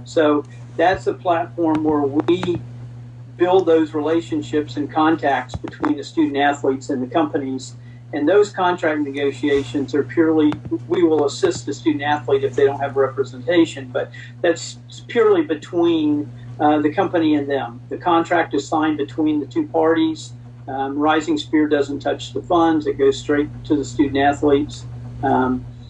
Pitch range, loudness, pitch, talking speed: 135-160 Hz, -19 LUFS, 150 Hz, 155 wpm